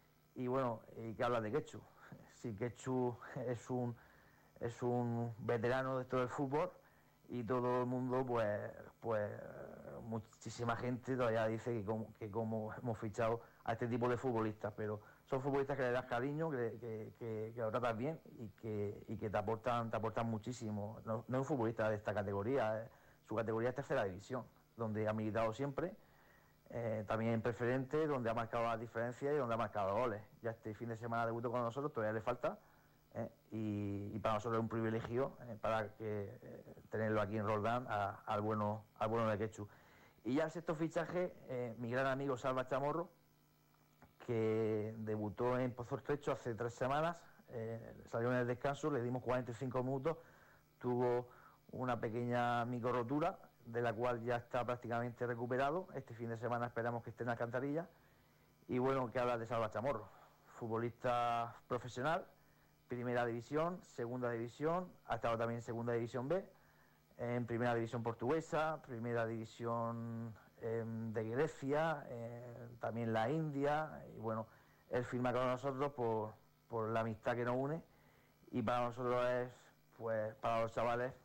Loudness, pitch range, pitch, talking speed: -41 LUFS, 115-125 Hz, 120 Hz, 170 wpm